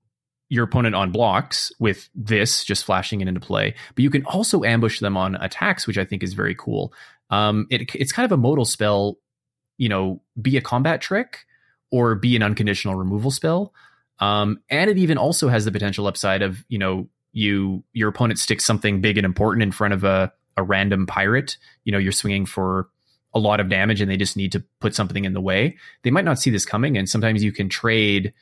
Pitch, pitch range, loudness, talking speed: 105 Hz, 100-120 Hz, -21 LUFS, 215 wpm